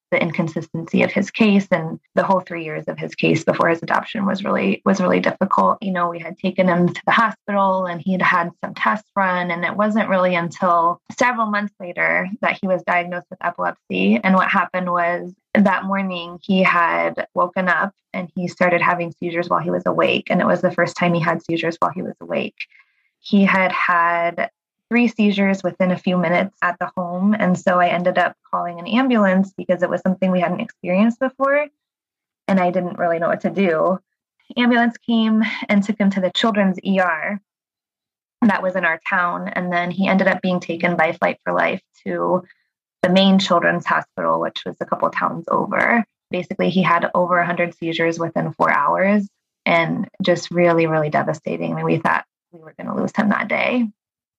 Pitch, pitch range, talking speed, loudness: 185 Hz, 175-200 Hz, 200 wpm, -19 LUFS